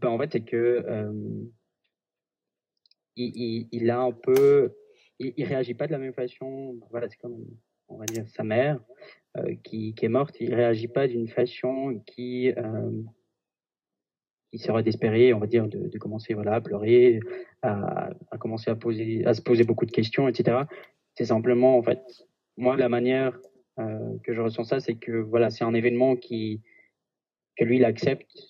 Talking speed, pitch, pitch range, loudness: 180 wpm, 120 Hz, 115-125 Hz, -26 LUFS